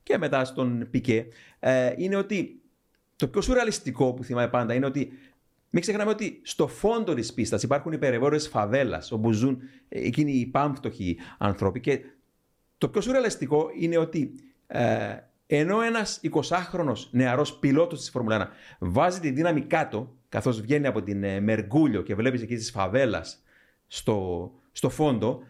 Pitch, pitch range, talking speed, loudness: 130 Hz, 115-155 Hz, 145 wpm, -26 LUFS